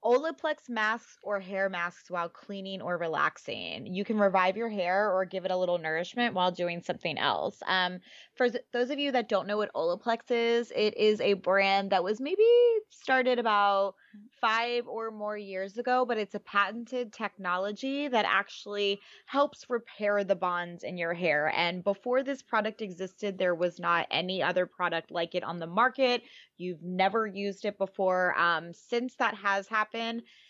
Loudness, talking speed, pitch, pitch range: -29 LUFS, 175 wpm, 205 Hz, 180-235 Hz